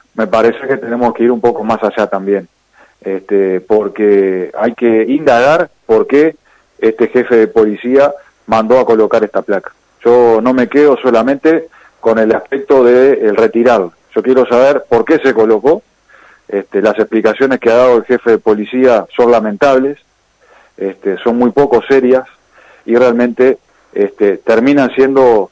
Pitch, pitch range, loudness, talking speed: 120 Hz, 110-130 Hz, -11 LUFS, 160 wpm